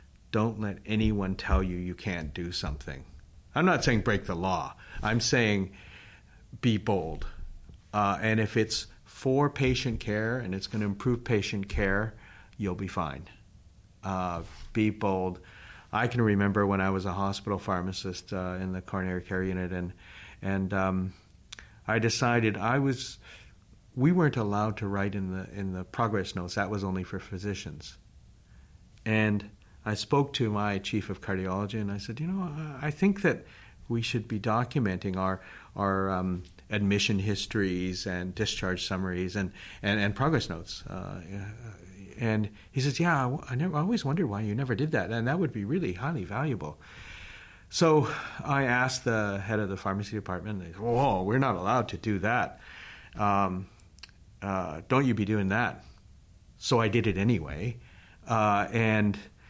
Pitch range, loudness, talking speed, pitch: 95-115 Hz, -30 LUFS, 165 wpm, 100 Hz